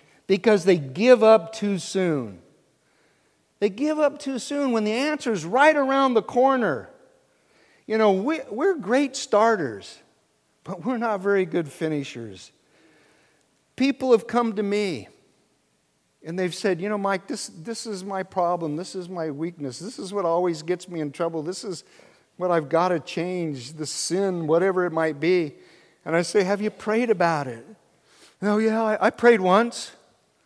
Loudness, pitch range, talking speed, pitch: -23 LUFS, 165-225 Hz, 170 wpm, 195 Hz